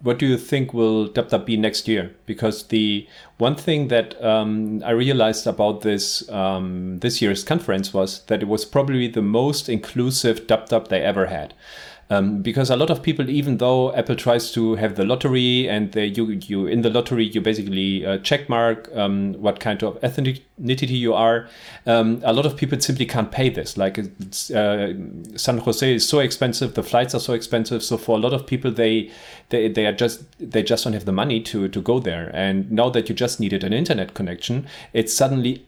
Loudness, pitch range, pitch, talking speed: -21 LUFS, 105-125 Hz, 115 Hz, 205 wpm